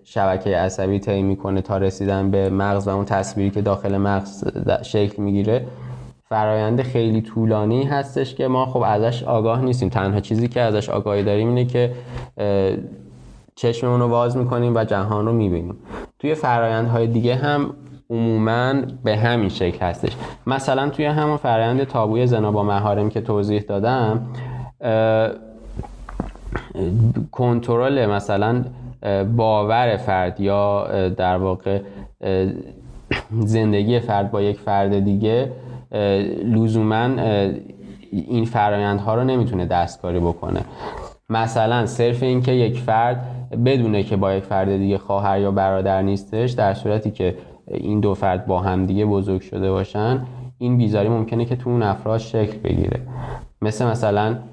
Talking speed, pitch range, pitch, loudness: 135 wpm, 100-120 Hz, 110 Hz, -20 LUFS